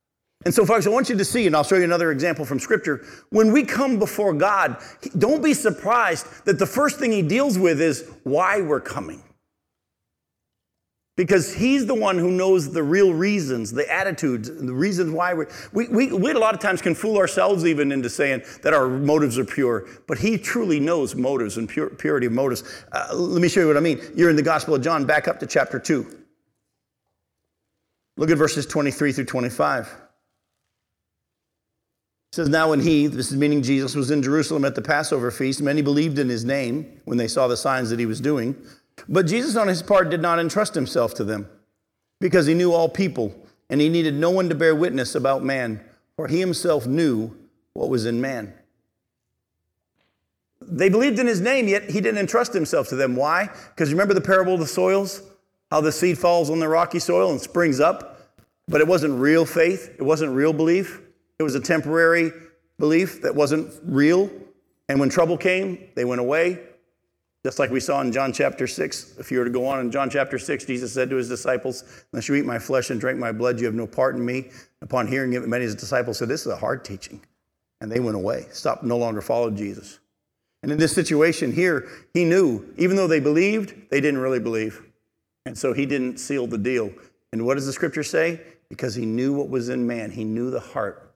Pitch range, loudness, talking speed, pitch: 125-180 Hz, -21 LUFS, 215 wpm, 155 Hz